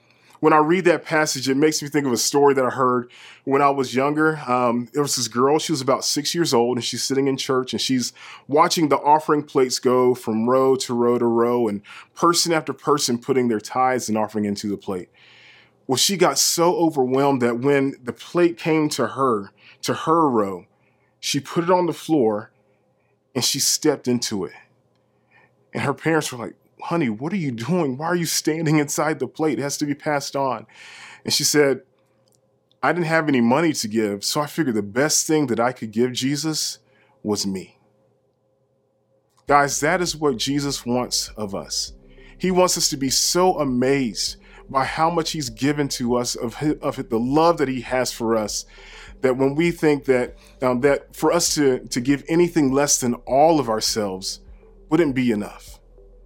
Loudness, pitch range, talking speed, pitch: -20 LUFS, 120-155 Hz, 195 wpm, 135 Hz